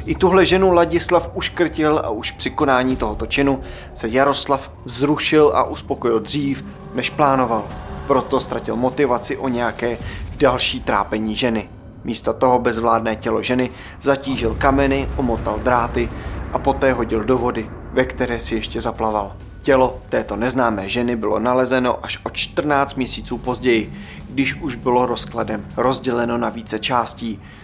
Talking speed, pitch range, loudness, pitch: 140 wpm, 110-135 Hz, -19 LUFS, 120 Hz